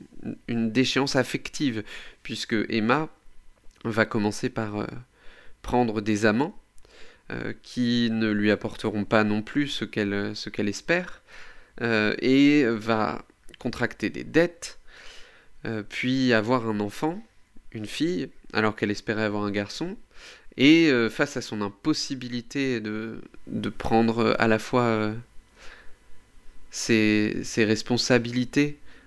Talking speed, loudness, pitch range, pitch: 125 wpm, -25 LUFS, 110-130 Hz, 115 Hz